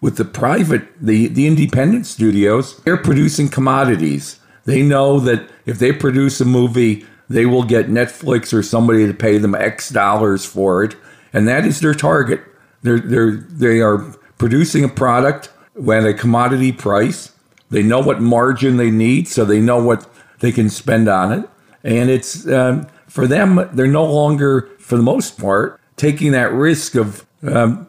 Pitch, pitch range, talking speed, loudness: 125 Hz, 110-140 Hz, 170 wpm, -15 LUFS